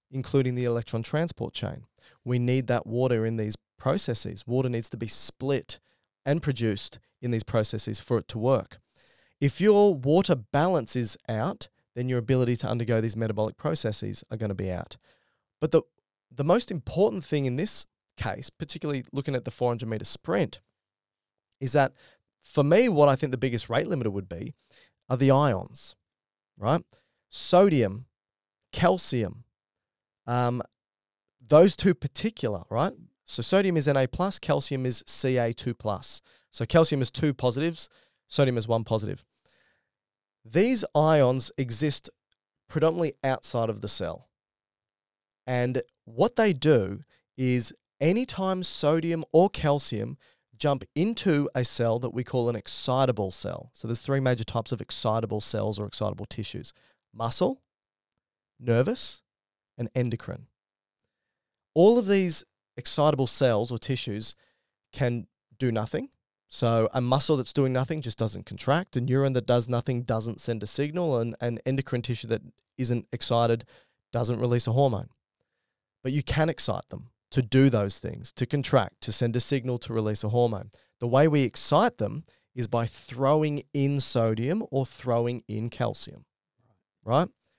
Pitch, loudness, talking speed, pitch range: 125 Hz, -26 LUFS, 150 wpm, 115-140 Hz